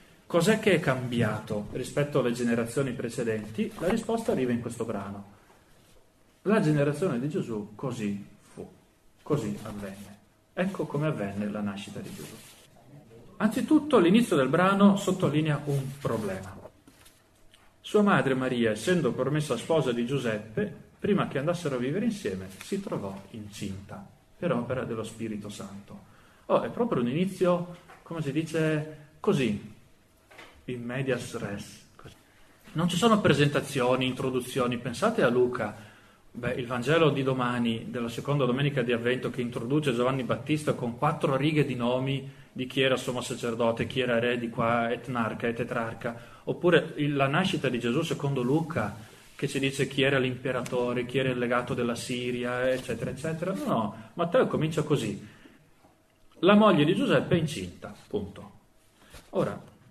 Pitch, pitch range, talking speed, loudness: 125 Hz, 115-150 Hz, 145 wpm, -28 LUFS